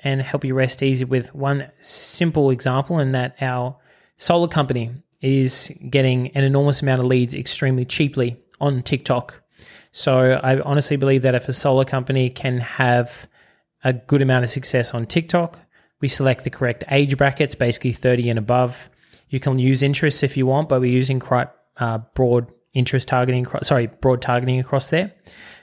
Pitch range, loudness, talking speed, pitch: 125-140 Hz, -20 LUFS, 170 wpm, 130 Hz